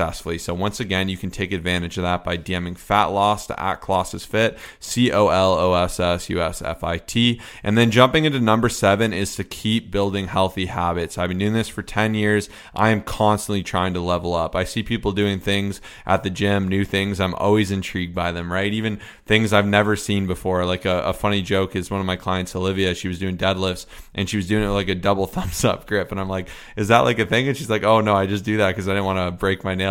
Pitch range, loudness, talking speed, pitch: 90-105 Hz, -21 LUFS, 255 wpm, 100 Hz